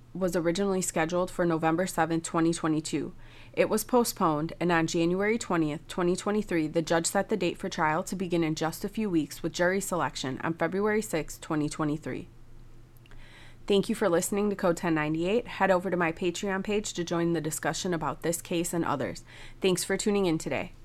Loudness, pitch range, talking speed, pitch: -28 LUFS, 155-190 Hz, 180 wpm, 170 Hz